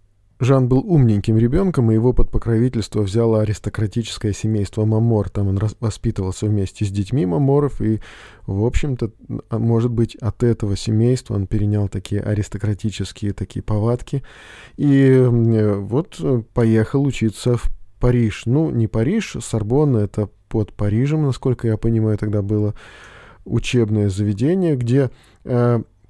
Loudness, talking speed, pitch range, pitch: -19 LUFS, 130 wpm, 105-125 Hz, 110 Hz